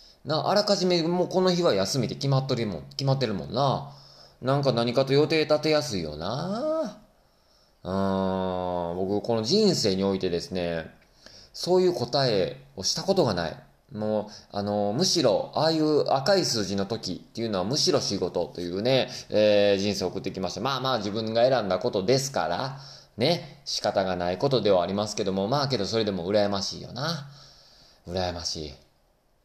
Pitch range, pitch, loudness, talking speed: 95-150 Hz, 115 Hz, -26 LUFS, 340 characters per minute